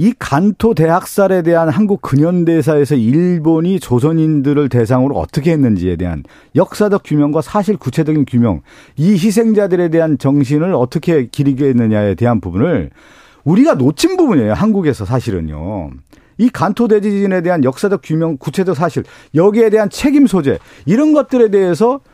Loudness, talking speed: -13 LUFS, 360 characters per minute